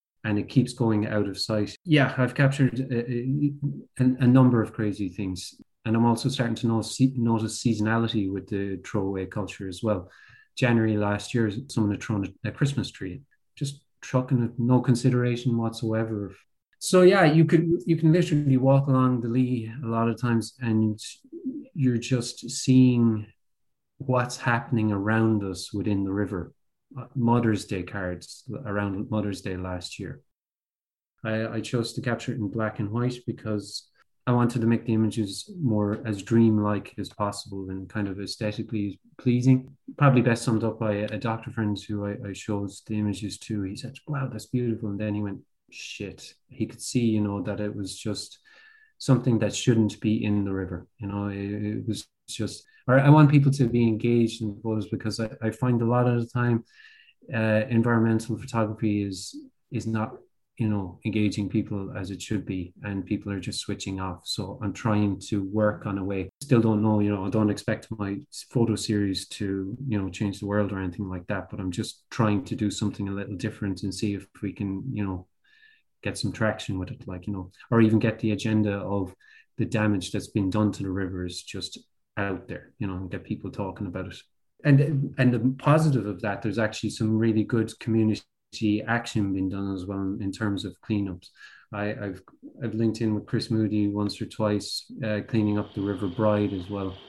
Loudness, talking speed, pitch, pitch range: -26 LUFS, 190 wpm, 110 Hz, 100-120 Hz